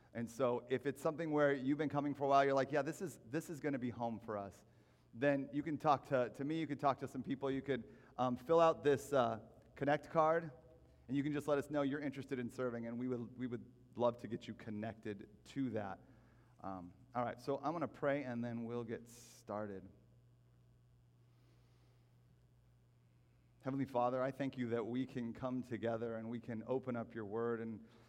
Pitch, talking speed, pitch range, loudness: 125 Hz, 215 wpm, 115-140 Hz, -40 LUFS